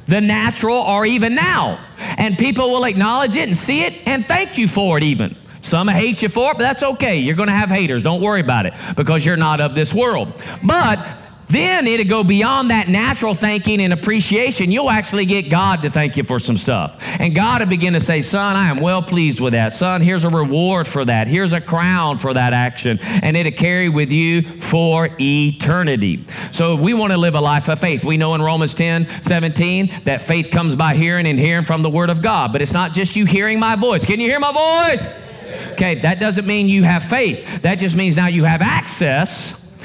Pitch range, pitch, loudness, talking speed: 160-205 Hz, 175 Hz, -16 LUFS, 220 wpm